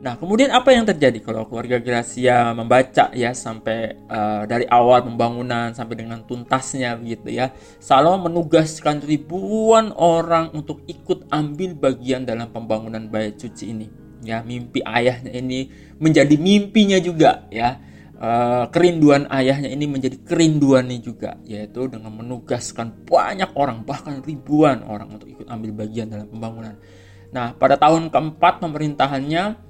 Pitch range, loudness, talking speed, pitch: 115-155 Hz, -19 LUFS, 135 wpm, 125 Hz